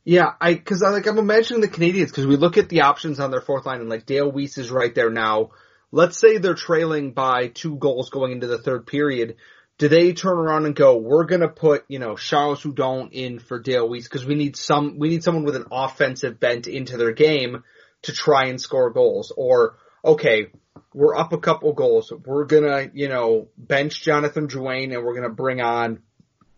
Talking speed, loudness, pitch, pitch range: 210 wpm, -20 LUFS, 145 Hz, 130-170 Hz